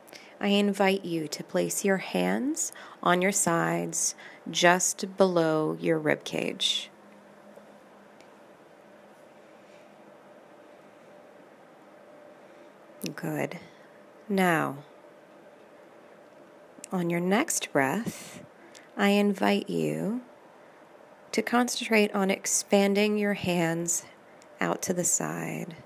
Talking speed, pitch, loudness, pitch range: 80 wpm, 190 Hz, -27 LUFS, 170-210 Hz